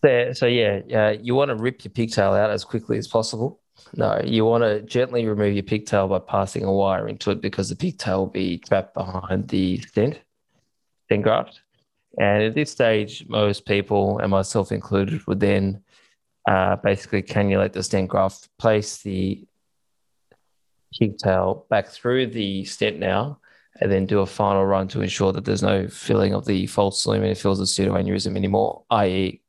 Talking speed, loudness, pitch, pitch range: 180 wpm, -22 LUFS, 100 Hz, 95-110 Hz